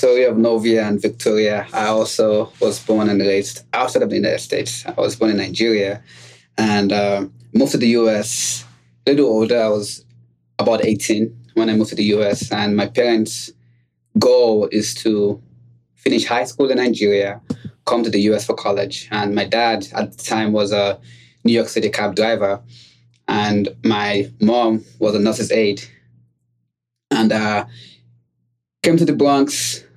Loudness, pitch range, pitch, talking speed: -18 LUFS, 100-115 Hz, 105 Hz, 165 wpm